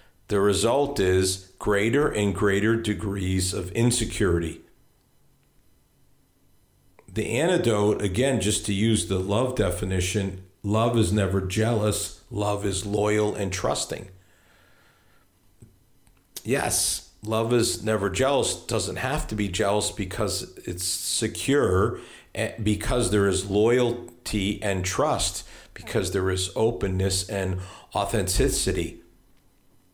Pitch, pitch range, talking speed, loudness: 100 Hz, 95-110 Hz, 105 wpm, -25 LUFS